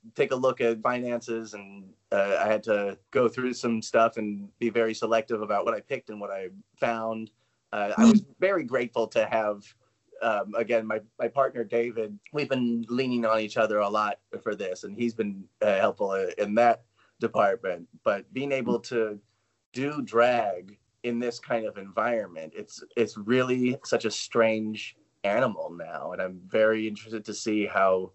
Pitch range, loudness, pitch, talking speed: 105-125 Hz, -27 LUFS, 115 Hz, 175 wpm